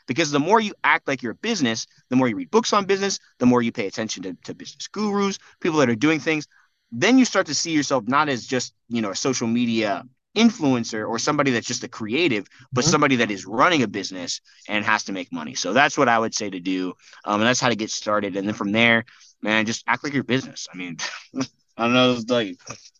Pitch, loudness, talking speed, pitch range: 125 Hz, -22 LUFS, 245 wpm, 115-155 Hz